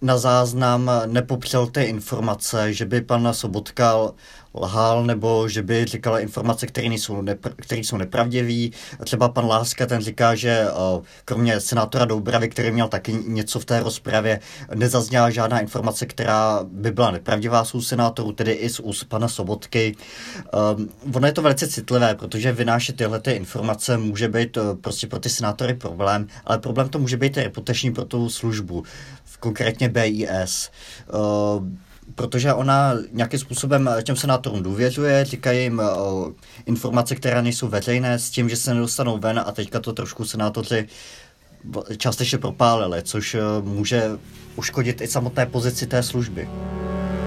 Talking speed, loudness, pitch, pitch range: 150 wpm, -22 LUFS, 115 Hz, 110-125 Hz